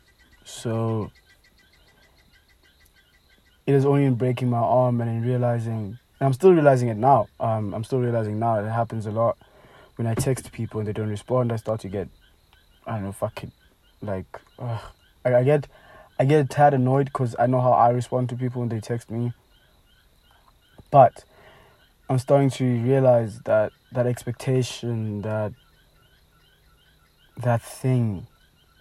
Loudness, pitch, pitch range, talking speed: -23 LUFS, 120 Hz, 105-125 Hz, 145 wpm